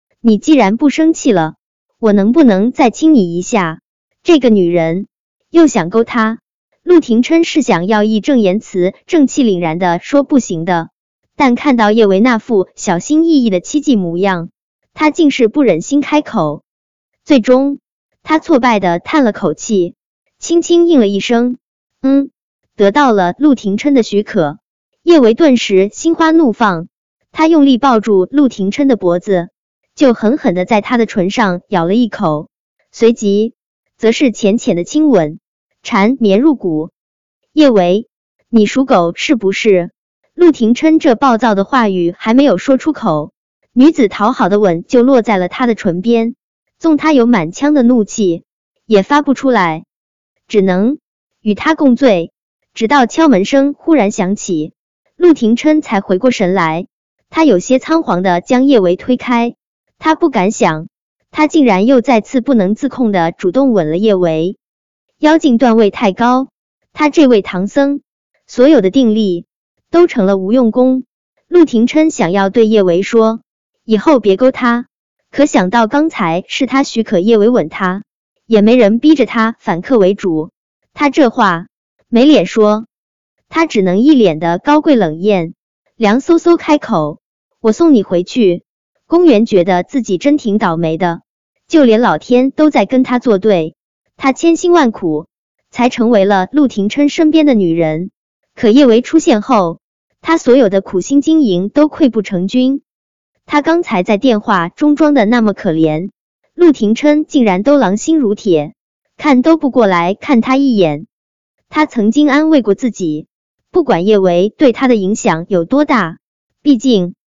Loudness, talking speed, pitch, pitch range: -11 LUFS, 225 characters per minute, 230 Hz, 195-280 Hz